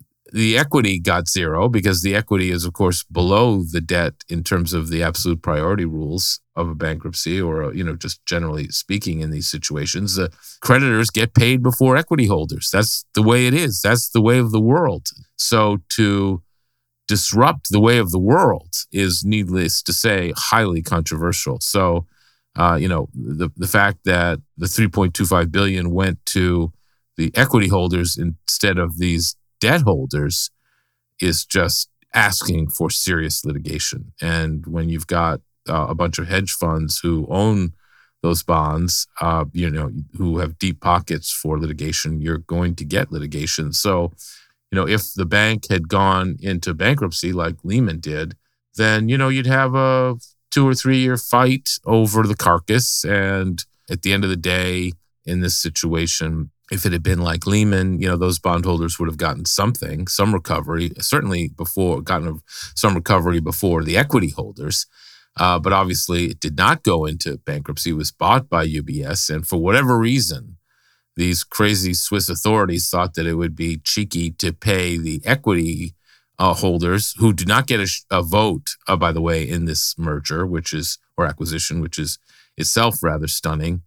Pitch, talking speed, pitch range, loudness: 90 Hz, 170 wpm, 85-105 Hz, -19 LUFS